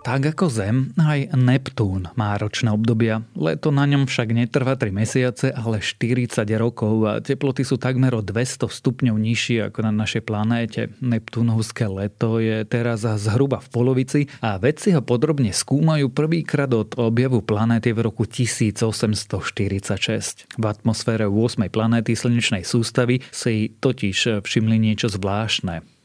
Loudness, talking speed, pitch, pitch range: -21 LUFS, 140 wpm, 115 Hz, 110-130 Hz